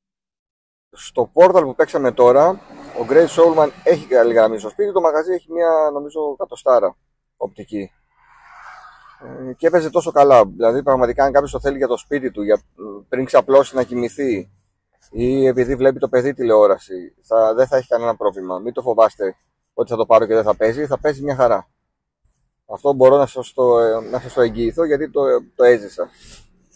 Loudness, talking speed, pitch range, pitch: -16 LUFS, 175 wpm, 115-155 Hz, 130 Hz